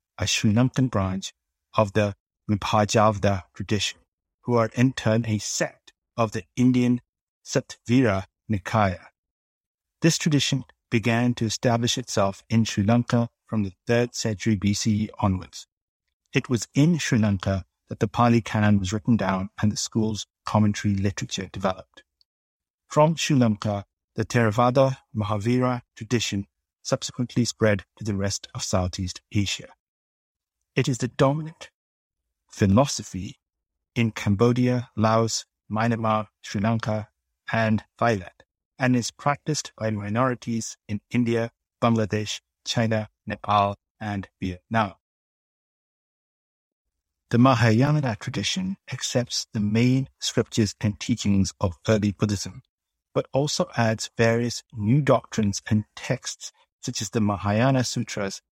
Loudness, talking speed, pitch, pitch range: -24 LUFS, 120 wpm, 110 Hz, 100-120 Hz